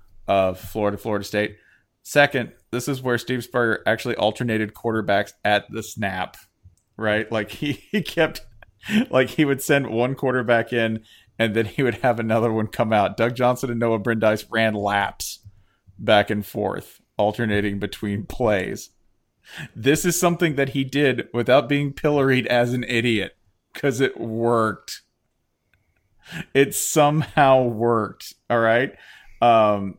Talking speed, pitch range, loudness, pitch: 140 wpm, 105-130 Hz, -21 LUFS, 115 Hz